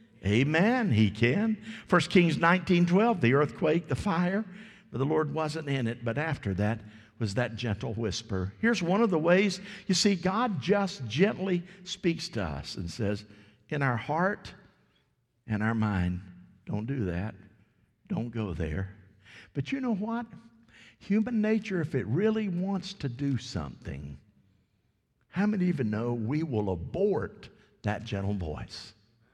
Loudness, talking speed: -29 LUFS, 150 wpm